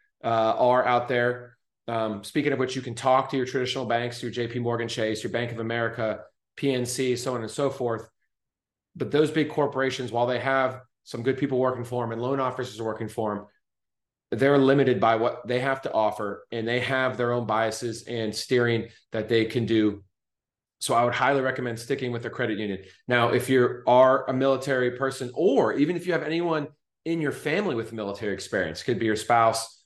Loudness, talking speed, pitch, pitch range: -25 LUFS, 205 wpm, 125 Hz, 115-130 Hz